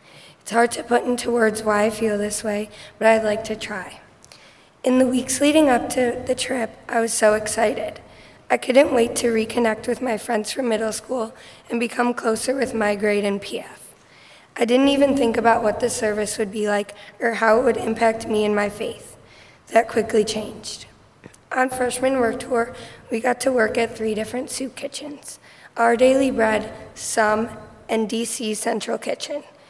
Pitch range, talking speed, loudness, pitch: 215-250 Hz, 185 wpm, -21 LUFS, 230 Hz